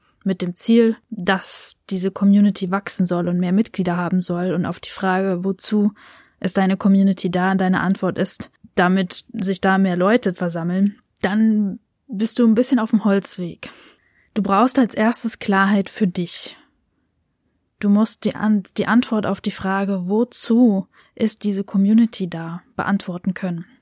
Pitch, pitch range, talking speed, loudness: 195 Hz, 185-215 Hz, 160 wpm, -19 LUFS